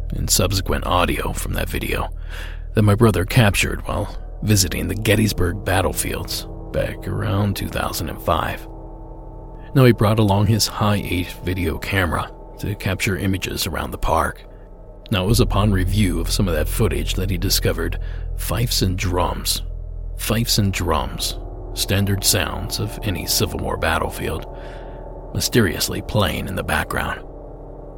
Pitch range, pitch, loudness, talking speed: 85-105 Hz, 95 Hz, -20 LUFS, 140 wpm